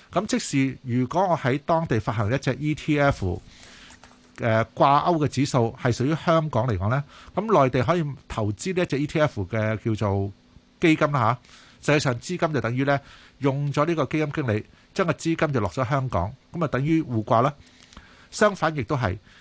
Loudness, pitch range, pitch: -24 LUFS, 115-155 Hz, 135 Hz